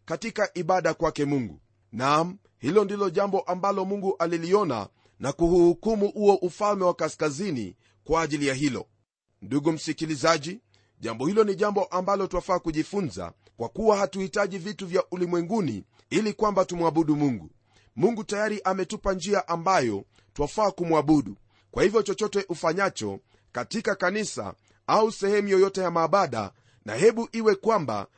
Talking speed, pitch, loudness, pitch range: 130 wpm, 175 Hz, -25 LUFS, 145-200 Hz